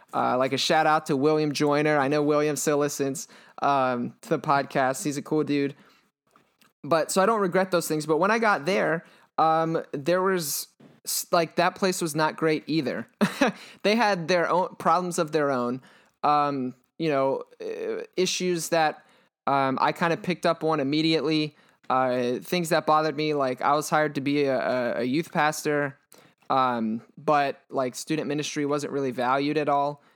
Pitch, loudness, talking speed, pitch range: 155 Hz, -25 LUFS, 175 wpm, 140-170 Hz